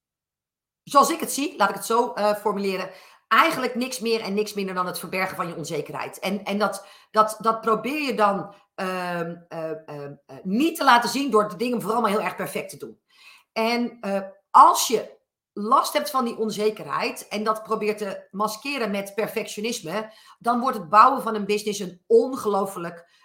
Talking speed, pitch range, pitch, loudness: 185 wpm, 195-235 Hz, 215 Hz, -23 LUFS